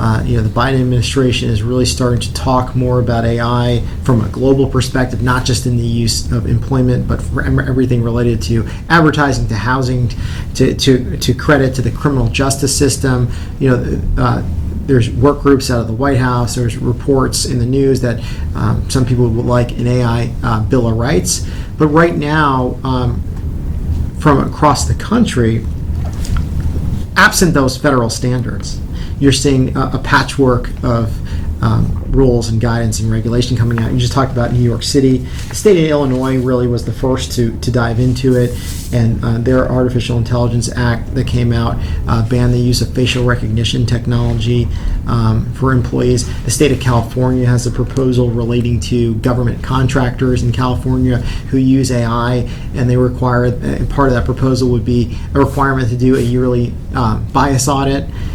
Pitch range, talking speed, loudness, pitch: 115-130 Hz, 175 wpm, -14 LUFS, 120 Hz